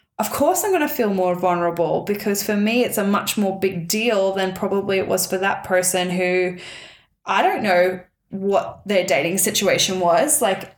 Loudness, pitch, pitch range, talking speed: -19 LUFS, 190 Hz, 180-205 Hz, 190 wpm